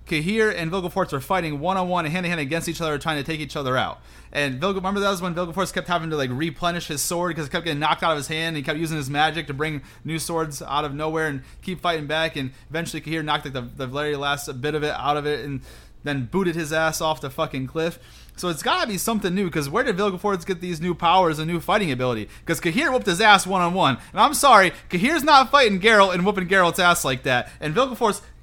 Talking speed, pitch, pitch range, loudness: 250 wpm, 165 Hz, 150-185 Hz, -22 LUFS